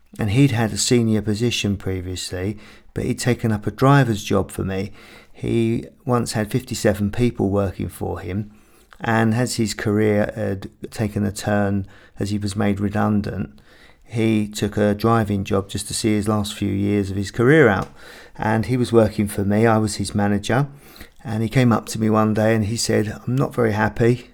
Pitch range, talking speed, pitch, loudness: 100-115 Hz, 190 wpm, 105 Hz, -21 LUFS